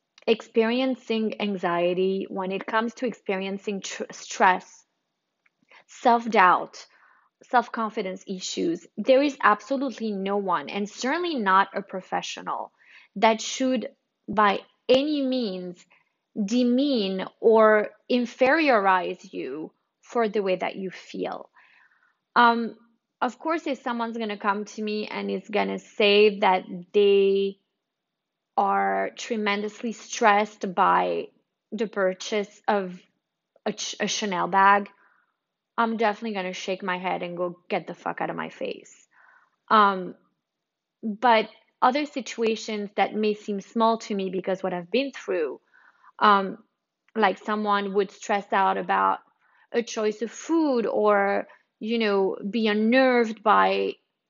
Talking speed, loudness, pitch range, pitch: 125 wpm, -24 LUFS, 195-235 Hz, 210 Hz